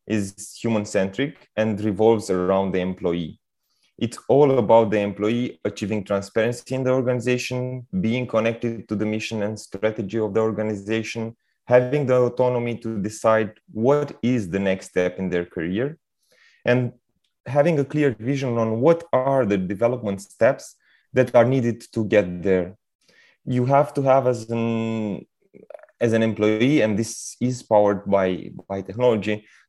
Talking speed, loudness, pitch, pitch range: 150 wpm, -22 LUFS, 115 Hz, 105-125 Hz